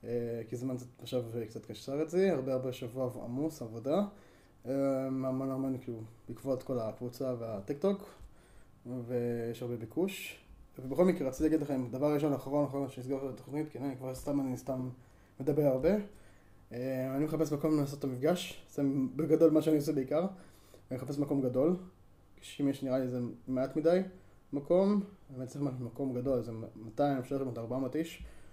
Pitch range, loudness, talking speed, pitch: 120-145 Hz, -34 LUFS, 170 wpm, 130 Hz